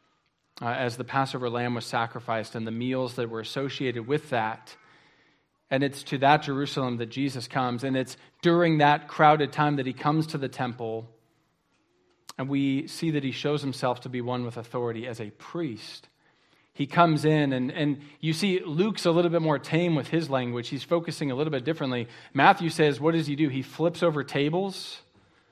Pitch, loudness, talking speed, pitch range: 140 Hz, -27 LUFS, 195 wpm, 125-155 Hz